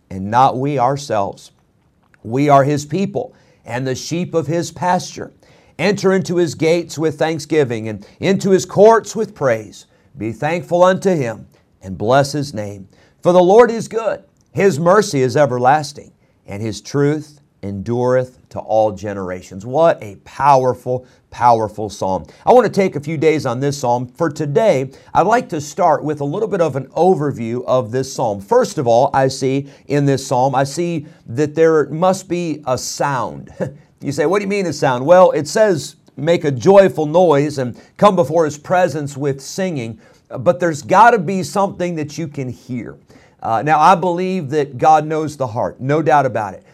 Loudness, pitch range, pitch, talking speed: -16 LUFS, 125-175 Hz, 145 Hz, 180 wpm